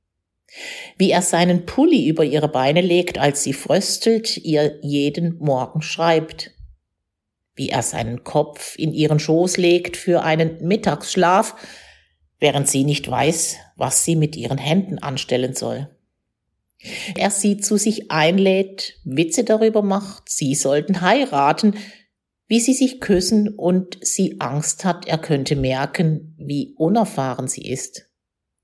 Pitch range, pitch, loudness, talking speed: 140-190 Hz, 160 Hz, -19 LUFS, 130 wpm